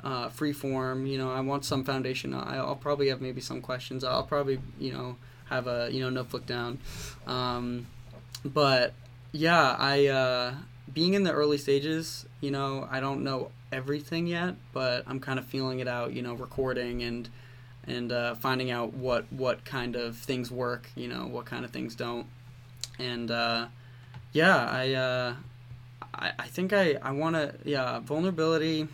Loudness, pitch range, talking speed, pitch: -30 LUFS, 120-140 Hz, 175 wpm, 130 Hz